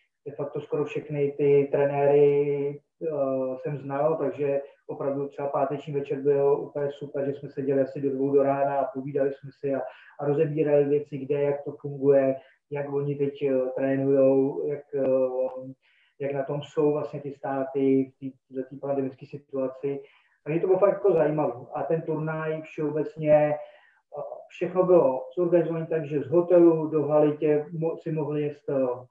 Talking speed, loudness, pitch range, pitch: 165 wpm, -26 LUFS, 135-150 Hz, 145 Hz